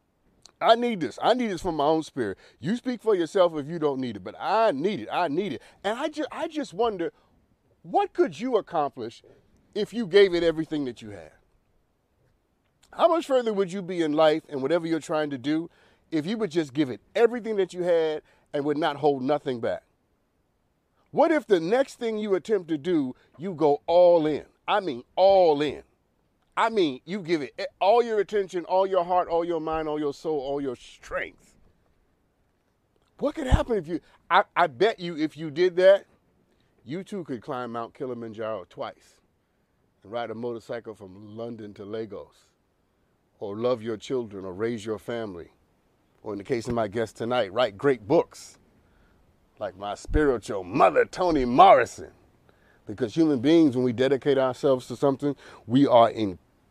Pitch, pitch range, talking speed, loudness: 155 Hz, 125-195 Hz, 185 wpm, -25 LUFS